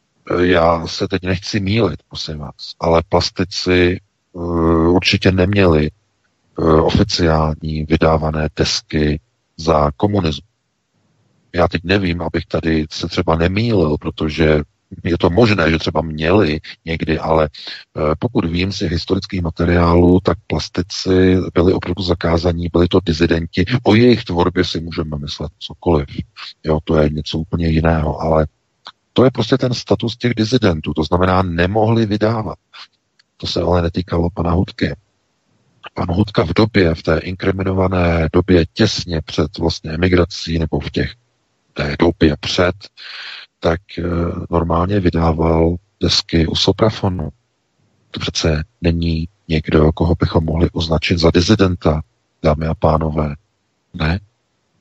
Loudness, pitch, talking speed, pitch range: -16 LUFS, 85 Hz, 125 wpm, 80-95 Hz